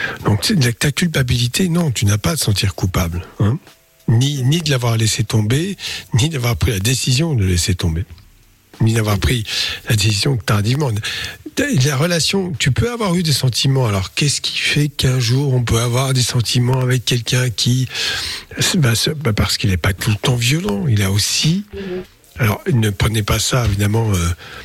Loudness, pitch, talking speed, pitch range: -17 LUFS, 125 Hz, 180 wpm, 105-140 Hz